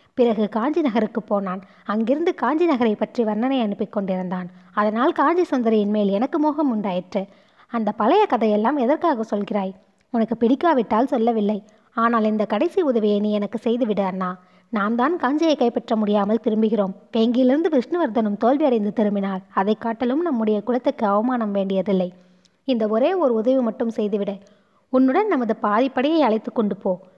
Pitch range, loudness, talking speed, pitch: 205-255 Hz, -21 LUFS, 135 wpm, 225 Hz